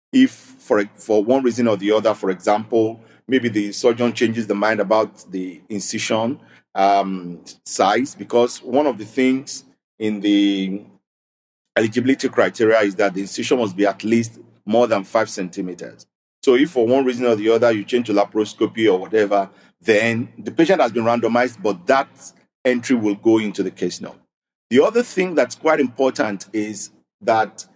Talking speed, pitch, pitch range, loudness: 170 wpm, 110 Hz, 100-125 Hz, -19 LUFS